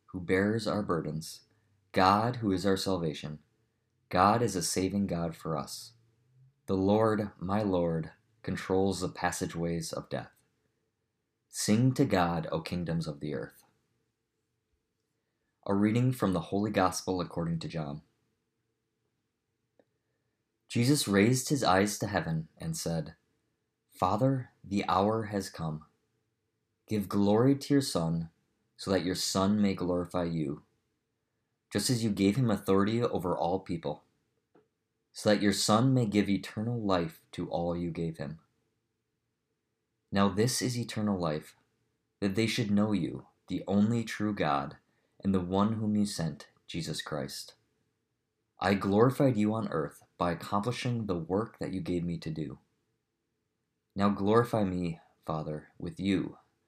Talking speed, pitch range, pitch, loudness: 140 wpm, 90-110 Hz, 100 Hz, -30 LUFS